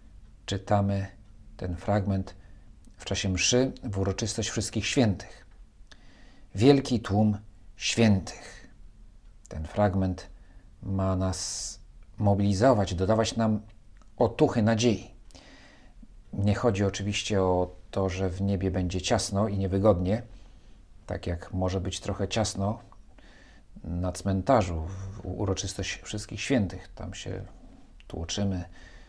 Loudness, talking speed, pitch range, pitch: -28 LUFS, 100 wpm, 95-110 Hz, 100 Hz